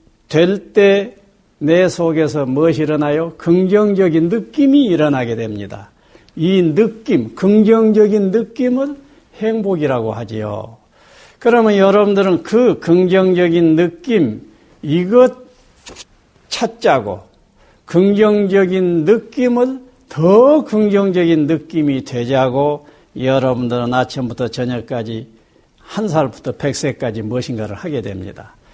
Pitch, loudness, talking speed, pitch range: 170 Hz, -14 LUFS, 240 characters per minute, 130-210 Hz